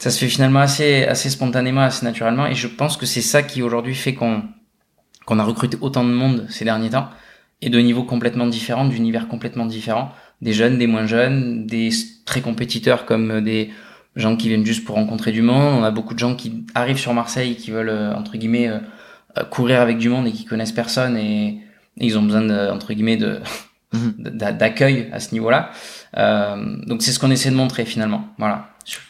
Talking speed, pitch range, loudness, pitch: 205 wpm, 110-125 Hz, -19 LUFS, 120 Hz